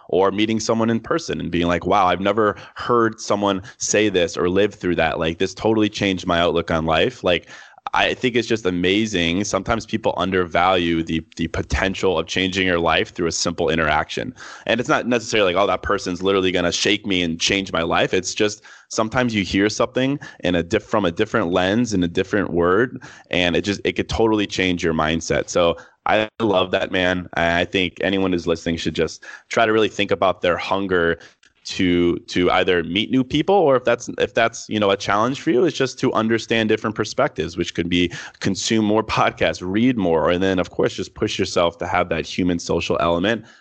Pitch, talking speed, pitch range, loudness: 95 Hz, 210 wpm, 85-110 Hz, -20 LUFS